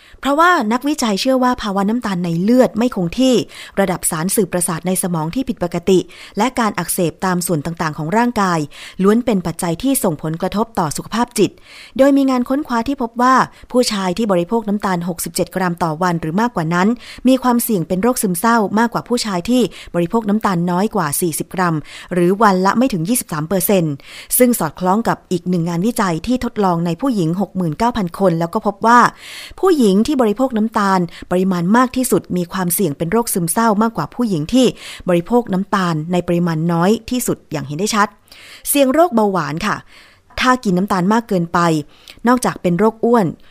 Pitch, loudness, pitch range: 195 Hz, -16 LUFS, 175-235 Hz